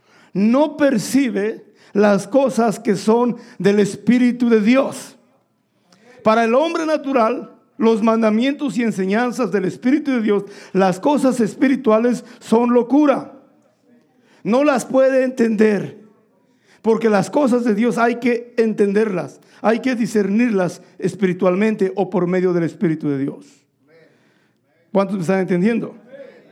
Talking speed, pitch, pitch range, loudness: 120 wpm, 225 Hz, 200-245 Hz, -18 LUFS